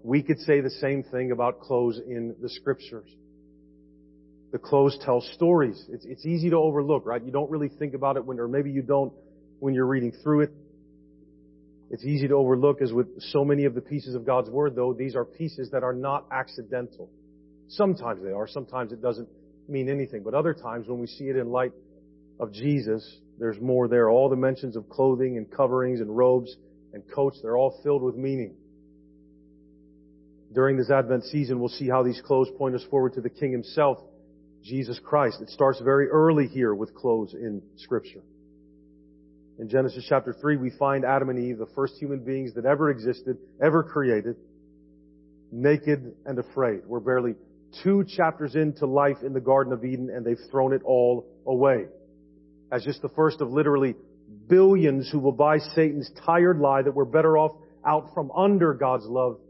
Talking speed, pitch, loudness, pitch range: 185 wpm, 130 Hz, -25 LUFS, 110-140 Hz